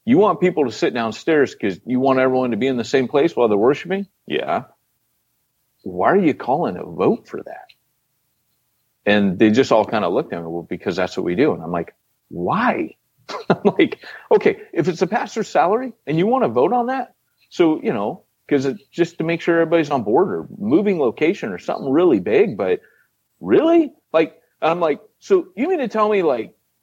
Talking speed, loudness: 210 wpm, -19 LUFS